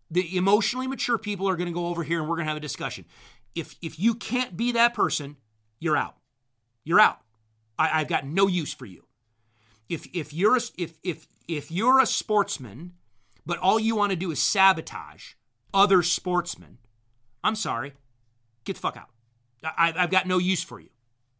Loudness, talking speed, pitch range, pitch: -25 LUFS, 190 wpm, 120-190 Hz, 165 Hz